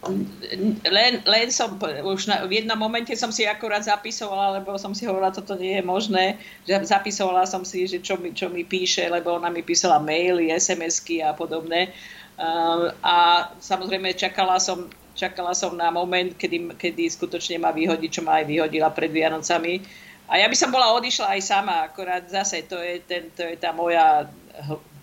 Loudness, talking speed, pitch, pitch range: -22 LUFS, 180 wpm, 185 Hz, 170-195 Hz